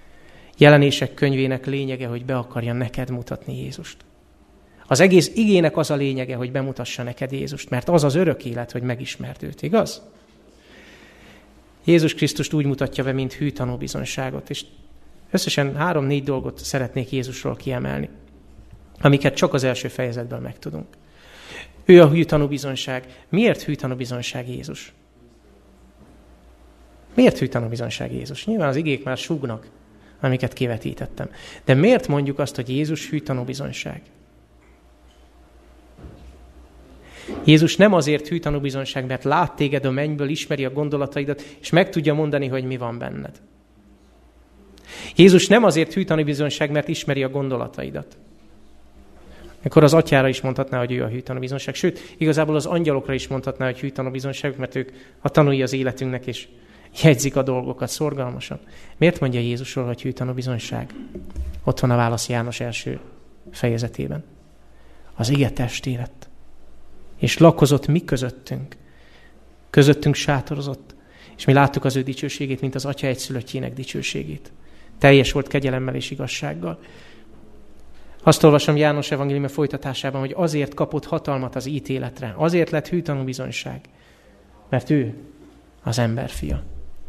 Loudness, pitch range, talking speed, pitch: -21 LUFS, 120-145 Hz, 135 wpm, 135 Hz